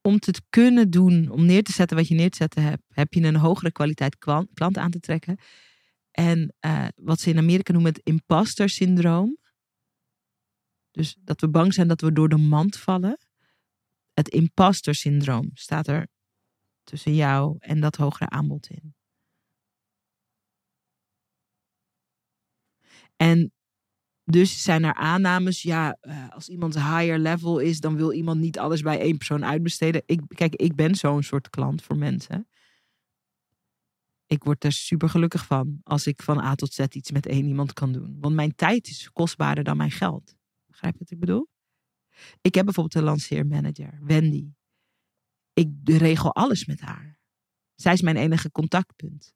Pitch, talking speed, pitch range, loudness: 160 Hz, 160 wpm, 150-170 Hz, -23 LUFS